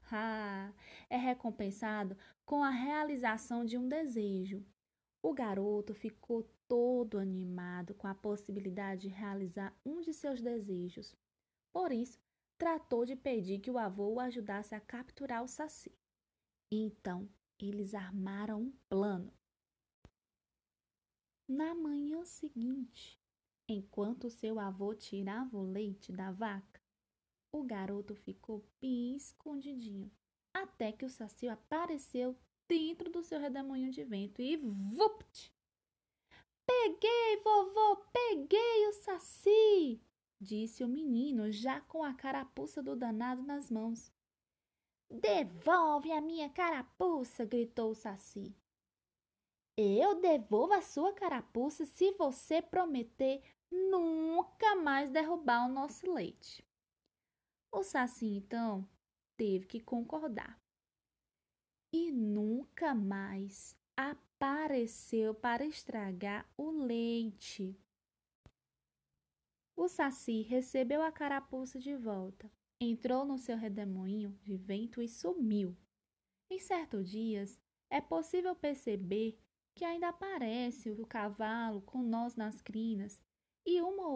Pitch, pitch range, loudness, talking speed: 240 Hz, 210-300 Hz, -37 LUFS, 110 wpm